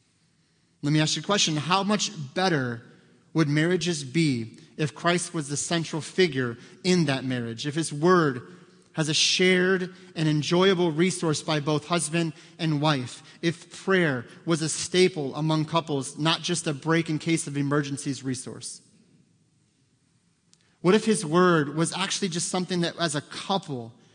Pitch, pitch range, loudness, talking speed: 160 Hz, 150-180 Hz, -25 LUFS, 155 wpm